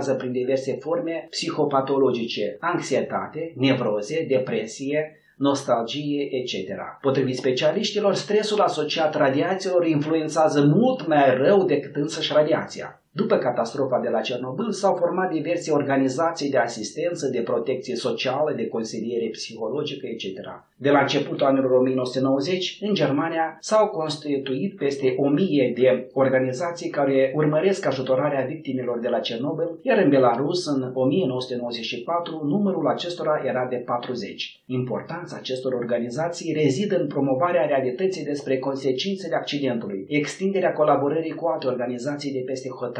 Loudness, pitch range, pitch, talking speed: -23 LUFS, 130-160 Hz, 140 Hz, 120 wpm